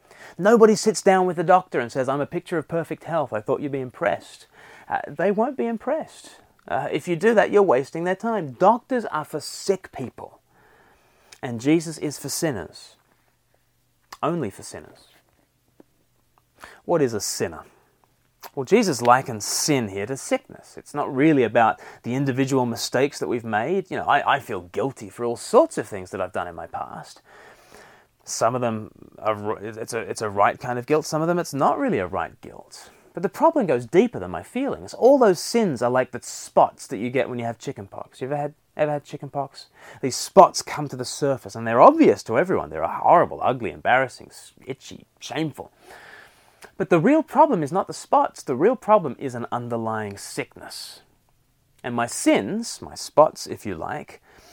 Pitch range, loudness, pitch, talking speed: 125-190 Hz, -22 LUFS, 145 Hz, 190 wpm